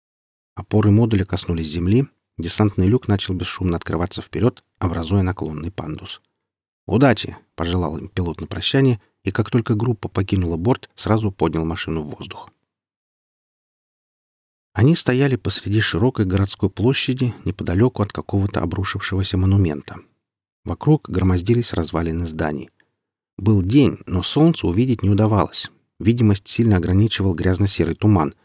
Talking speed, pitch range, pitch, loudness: 120 wpm, 85-115 Hz, 100 Hz, -20 LUFS